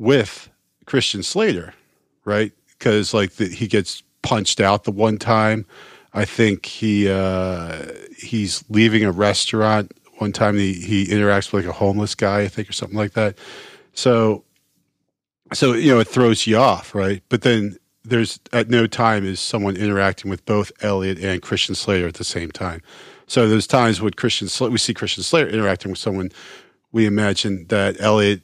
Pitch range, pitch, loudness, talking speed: 95-110 Hz, 105 Hz, -19 LUFS, 175 wpm